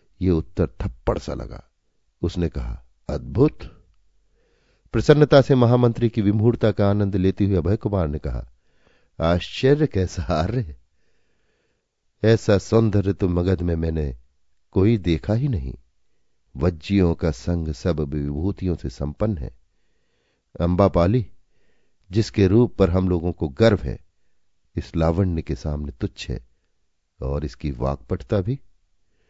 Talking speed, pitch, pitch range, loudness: 125 wpm, 90 Hz, 80-105 Hz, -22 LUFS